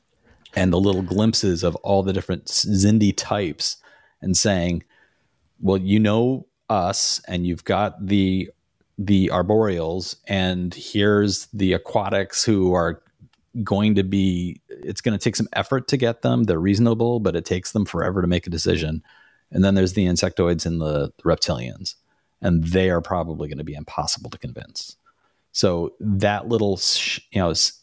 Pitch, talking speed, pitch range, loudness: 95 Hz, 160 wpm, 90-105 Hz, -21 LUFS